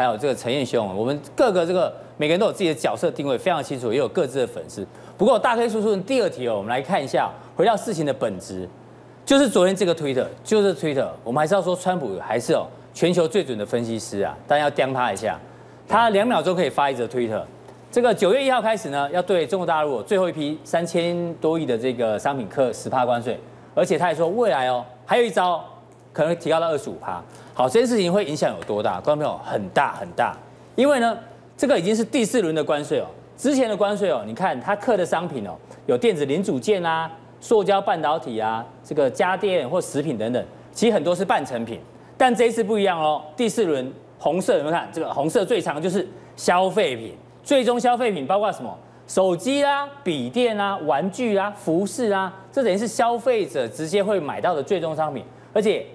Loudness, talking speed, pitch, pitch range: -22 LUFS, 335 characters per minute, 190 Hz, 150-230 Hz